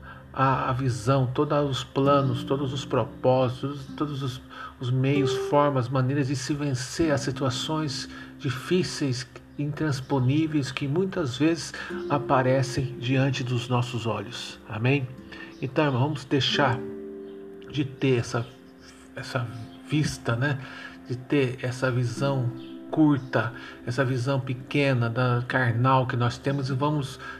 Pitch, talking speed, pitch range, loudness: 130 Hz, 120 wpm, 125-140 Hz, -26 LUFS